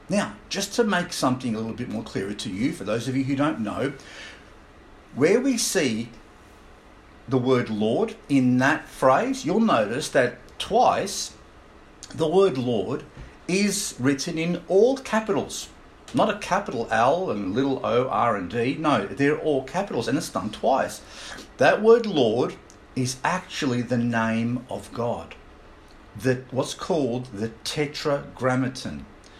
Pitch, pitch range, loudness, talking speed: 130 Hz, 120-175 Hz, -24 LUFS, 145 wpm